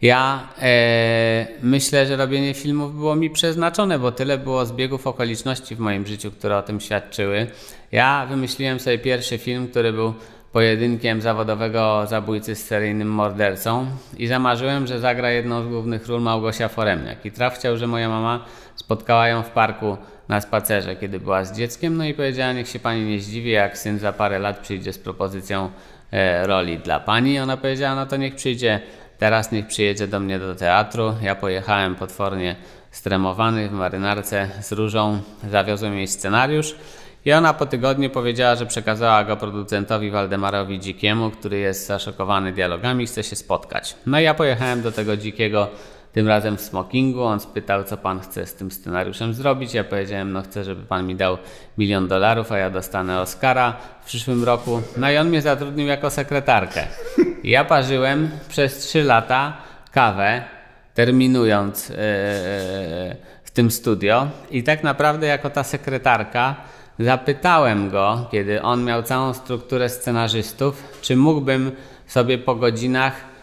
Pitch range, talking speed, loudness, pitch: 100-130 Hz, 160 wpm, -21 LUFS, 115 Hz